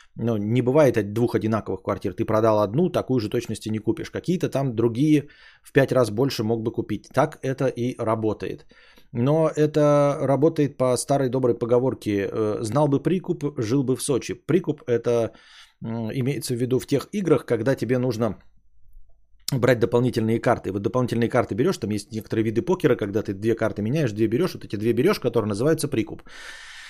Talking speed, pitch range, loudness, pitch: 185 wpm, 110-135 Hz, -23 LUFS, 120 Hz